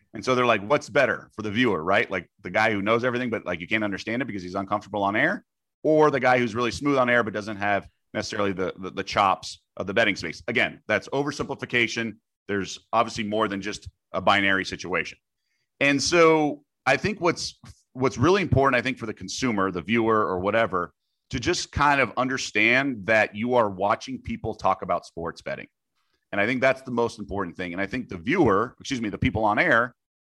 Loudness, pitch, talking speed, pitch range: -24 LUFS, 110 Hz, 215 wpm, 100-130 Hz